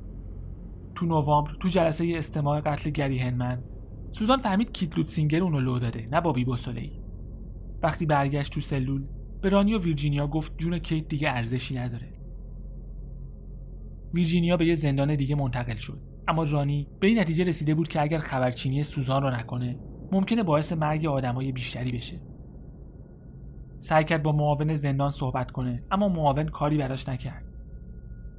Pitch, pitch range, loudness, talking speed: 145 Hz, 125-160 Hz, -27 LUFS, 145 wpm